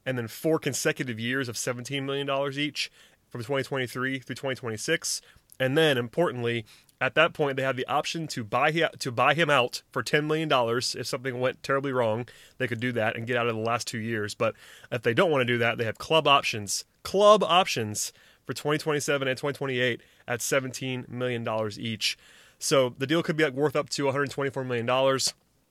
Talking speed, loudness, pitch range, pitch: 195 wpm, -27 LUFS, 120-145 Hz, 130 Hz